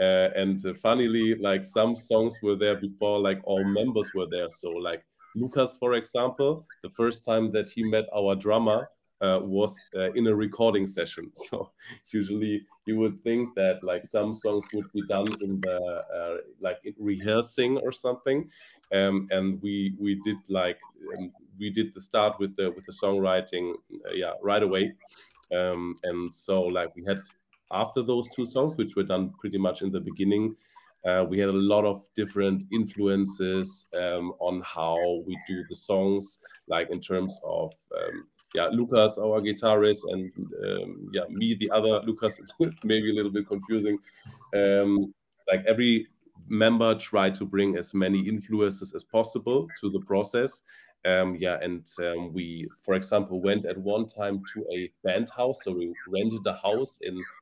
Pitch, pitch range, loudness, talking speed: 100 Hz, 95-110 Hz, -27 LUFS, 170 wpm